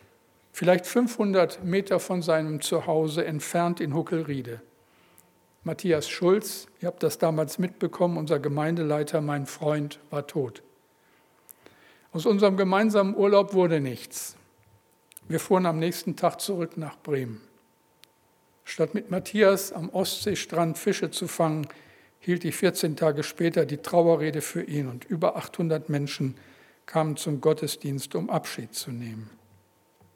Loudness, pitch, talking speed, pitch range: -26 LUFS, 165 Hz, 125 wpm, 145-180 Hz